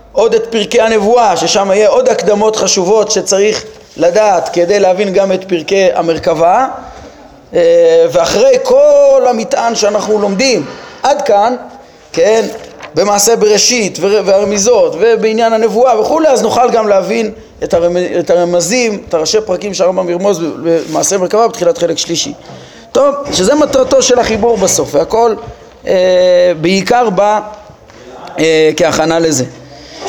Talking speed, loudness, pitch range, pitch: 120 wpm, -10 LUFS, 180-235 Hz, 210 Hz